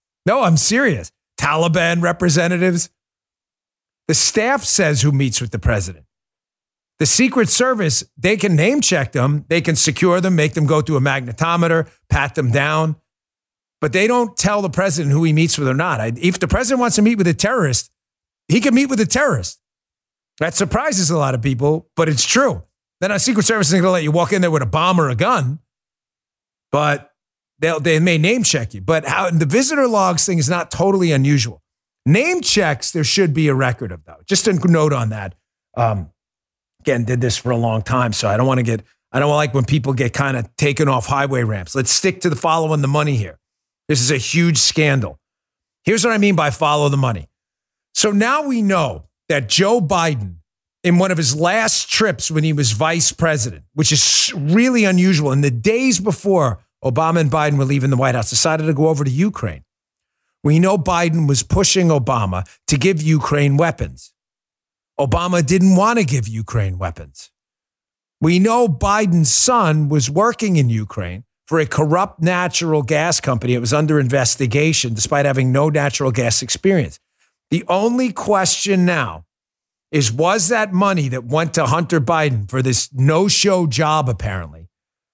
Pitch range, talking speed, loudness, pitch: 130-180 Hz, 190 wpm, -16 LUFS, 155 Hz